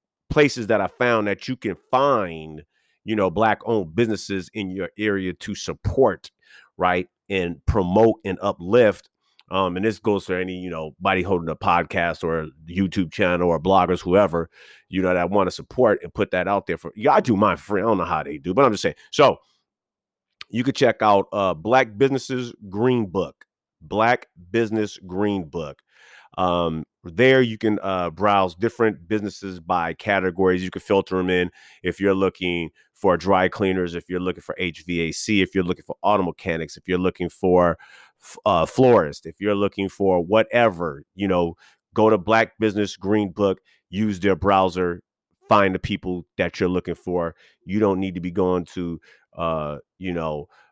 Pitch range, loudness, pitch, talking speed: 90-105 Hz, -22 LUFS, 95 Hz, 185 wpm